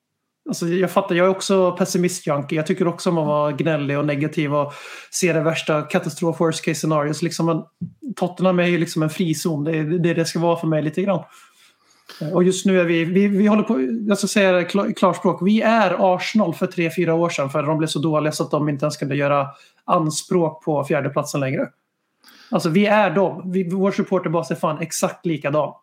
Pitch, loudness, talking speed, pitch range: 170 Hz, -20 LUFS, 205 wpm, 155-190 Hz